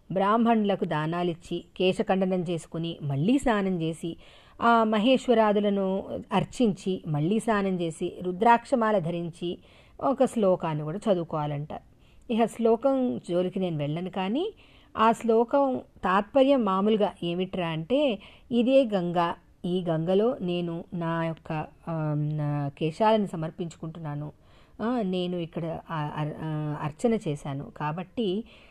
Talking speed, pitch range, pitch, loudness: 95 wpm, 165-220 Hz, 185 Hz, -27 LUFS